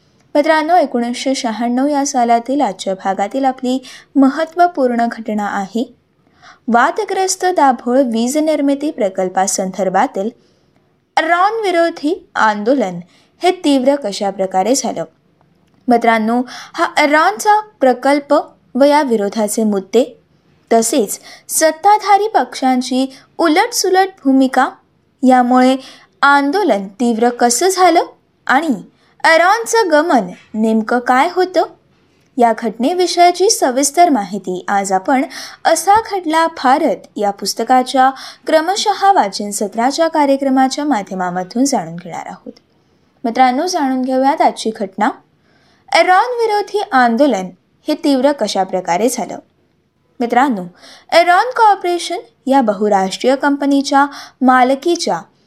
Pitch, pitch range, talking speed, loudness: 265 Hz, 230-330 Hz, 95 wpm, -14 LUFS